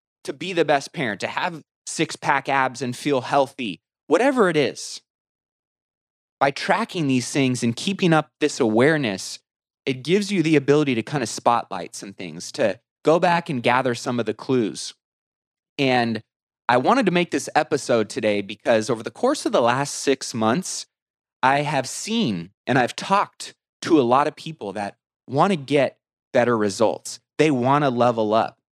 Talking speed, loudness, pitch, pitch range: 175 wpm, -22 LUFS, 135 Hz, 115-150 Hz